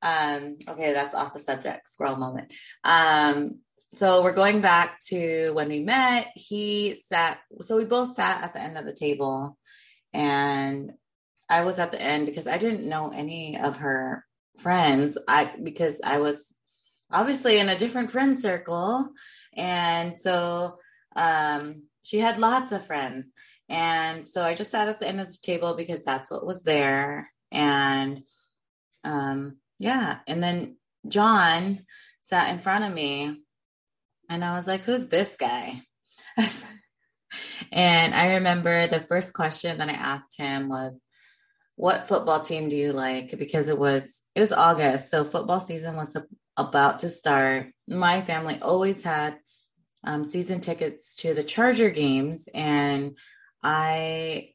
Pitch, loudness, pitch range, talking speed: 165 Hz, -25 LUFS, 145-190 Hz, 150 wpm